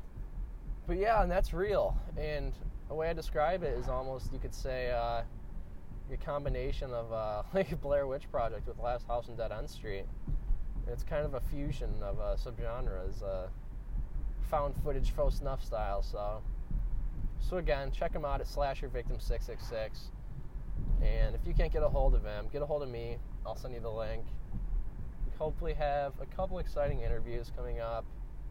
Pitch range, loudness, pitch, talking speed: 115-145 Hz, -37 LUFS, 125 Hz, 175 wpm